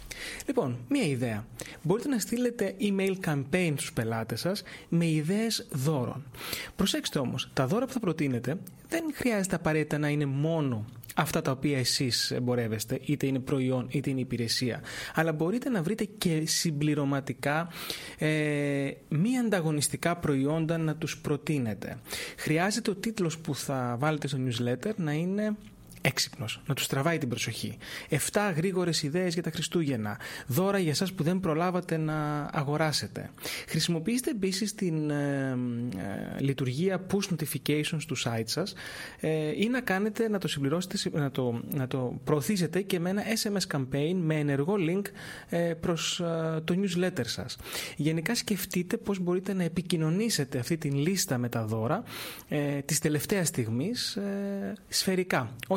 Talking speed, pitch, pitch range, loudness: 145 wpm, 160 Hz, 140-185 Hz, -30 LUFS